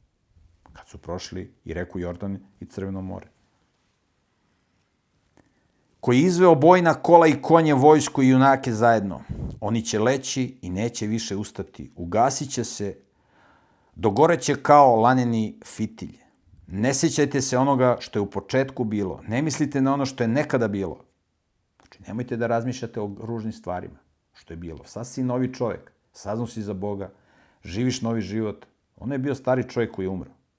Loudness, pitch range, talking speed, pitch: -22 LUFS, 100-135 Hz, 160 wpm, 115 Hz